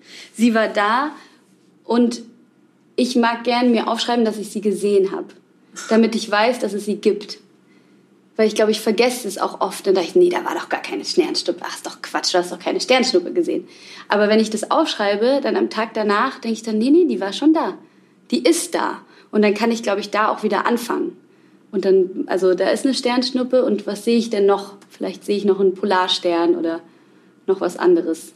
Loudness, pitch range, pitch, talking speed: -19 LUFS, 200-255 Hz, 220 Hz, 215 wpm